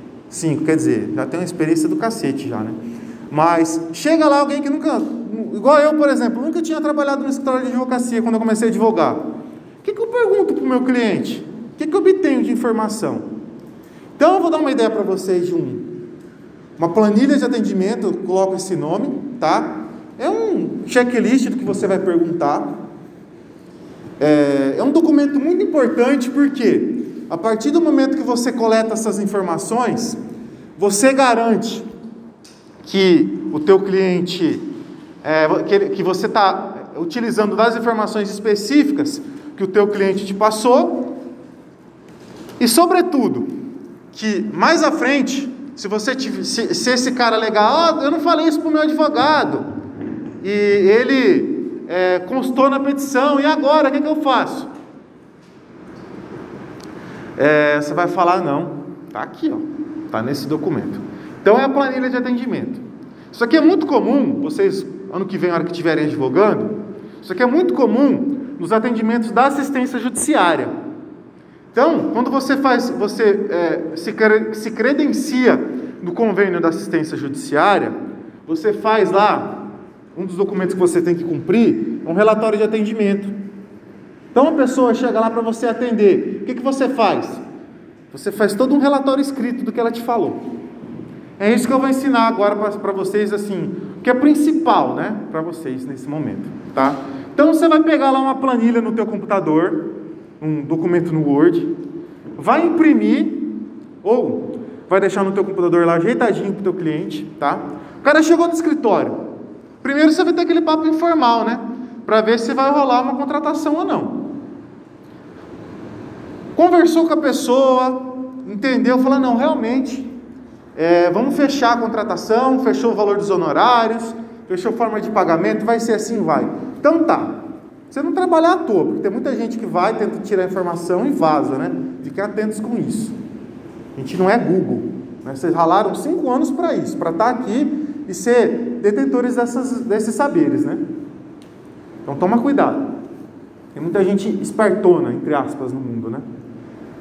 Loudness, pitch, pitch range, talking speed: -17 LUFS, 250 Hz, 205-295 Hz, 165 wpm